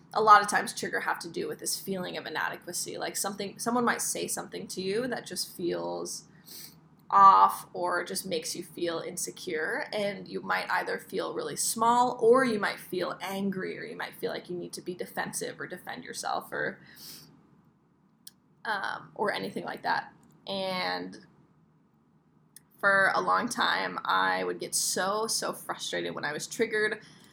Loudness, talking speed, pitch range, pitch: -29 LUFS, 170 wpm, 170-210 Hz, 190 Hz